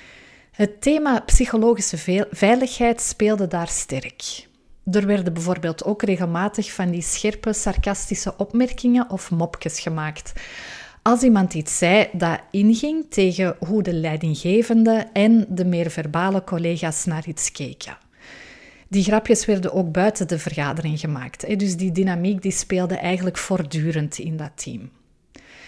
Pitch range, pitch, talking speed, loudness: 170-215 Hz, 190 Hz, 130 wpm, -21 LUFS